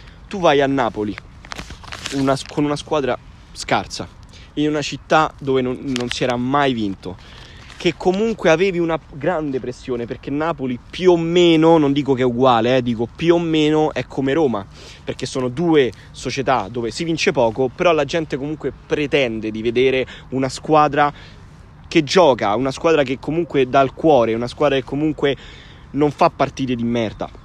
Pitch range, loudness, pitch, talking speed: 125-160 Hz, -18 LUFS, 140 Hz, 170 wpm